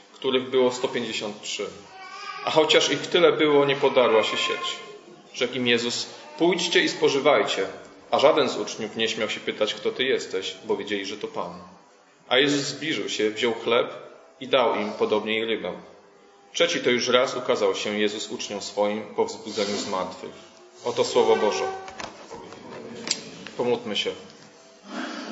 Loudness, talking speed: -24 LUFS, 150 wpm